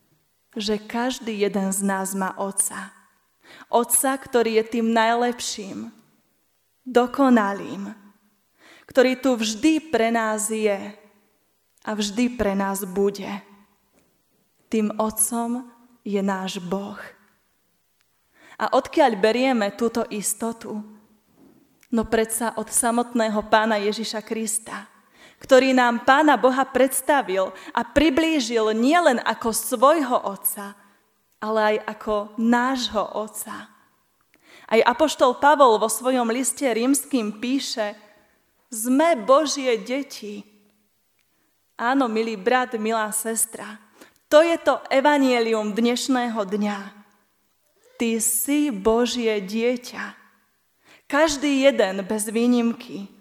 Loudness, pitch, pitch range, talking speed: -21 LUFS, 225 Hz, 210-255 Hz, 100 wpm